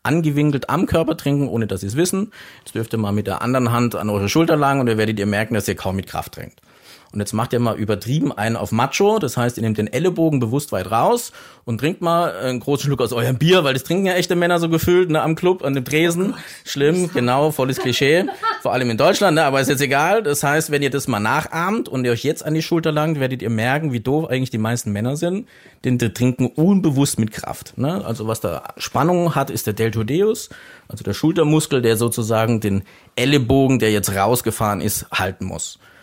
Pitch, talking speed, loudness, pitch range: 135 Hz, 230 wpm, -19 LUFS, 115-155 Hz